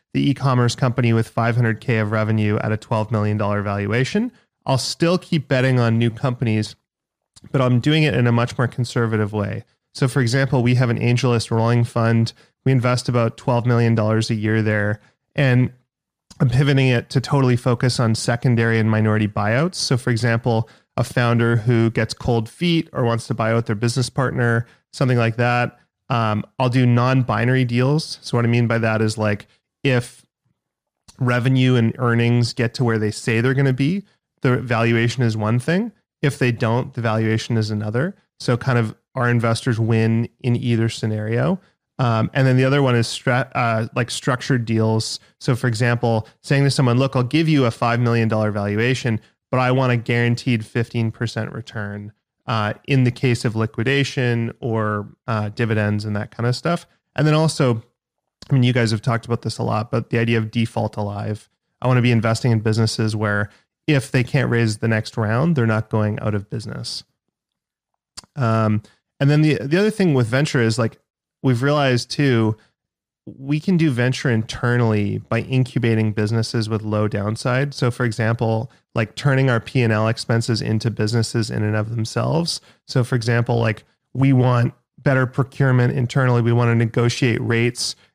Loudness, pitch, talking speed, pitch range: -20 LUFS, 120 Hz, 180 wpm, 115-130 Hz